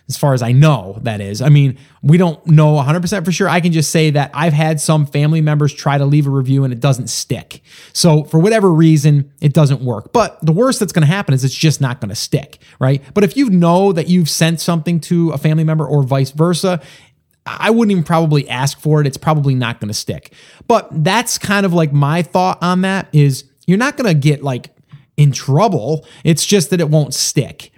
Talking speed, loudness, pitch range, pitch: 235 wpm, -14 LUFS, 140-175 Hz, 155 Hz